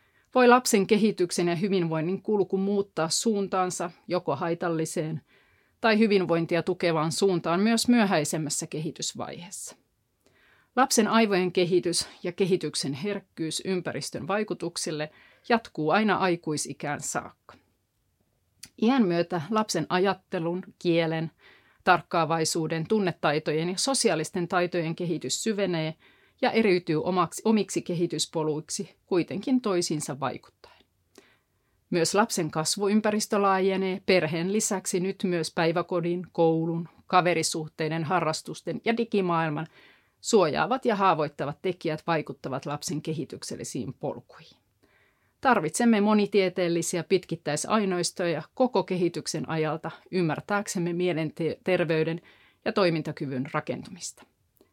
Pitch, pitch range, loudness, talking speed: 175 Hz, 160-195 Hz, -26 LUFS, 90 wpm